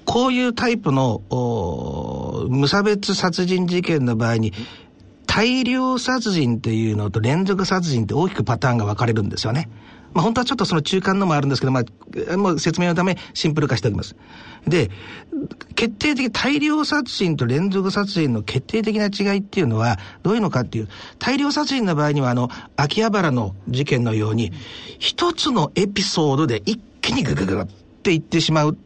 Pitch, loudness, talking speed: 160 Hz, -20 LUFS, 360 characters per minute